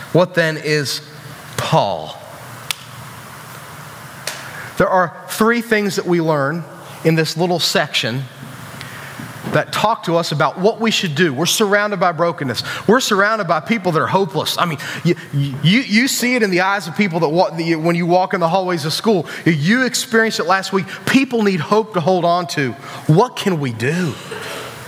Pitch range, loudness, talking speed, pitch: 145-195 Hz, -17 LUFS, 175 wpm, 170 Hz